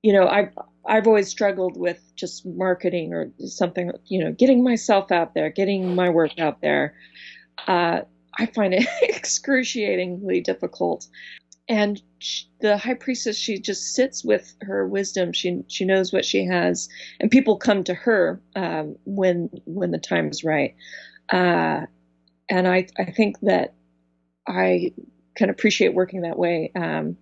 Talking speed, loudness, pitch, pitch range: 155 wpm, -22 LUFS, 185 Hz, 160-210 Hz